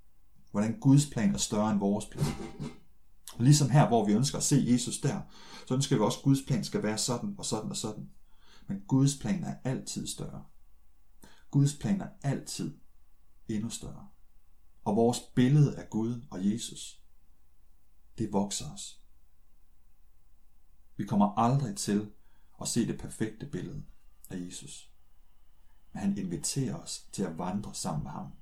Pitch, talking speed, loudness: 105 Hz, 160 wpm, -30 LUFS